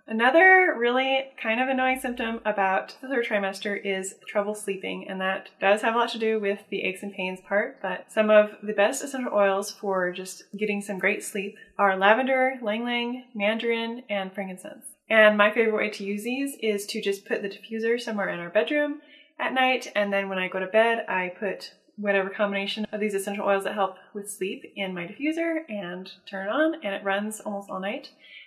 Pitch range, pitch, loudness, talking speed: 195-235 Hz, 210 Hz, -25 LUFS, 205 wpm